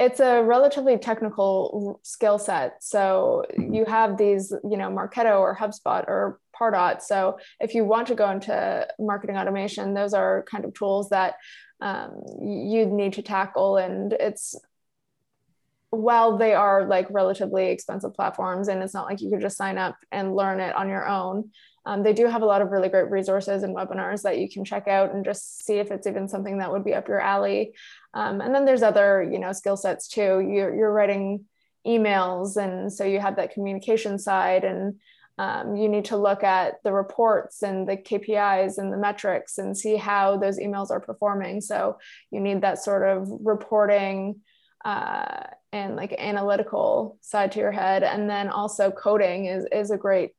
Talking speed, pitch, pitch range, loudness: 185 wpm, 200 Hz, 195-215 Hz, -24 LUFS